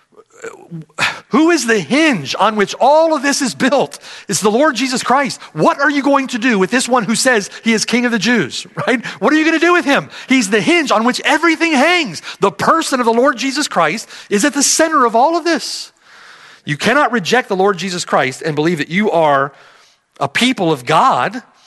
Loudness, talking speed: -14 LUFS, 220 wpm